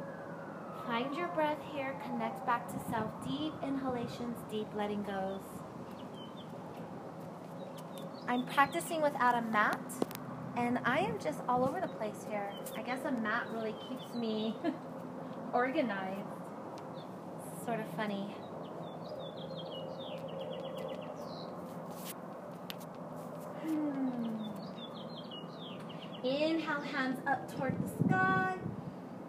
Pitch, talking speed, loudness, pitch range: 235 Hz, 95 wpm, -37 LUFS, 210-265 Hz